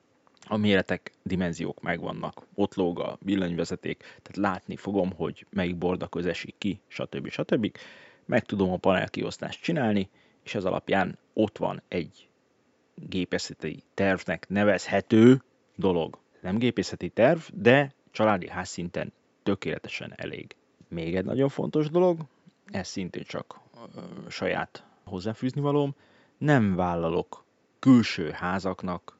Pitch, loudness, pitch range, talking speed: 100 Hz, -27 LUFS, 90-120 Hz, 115 wpm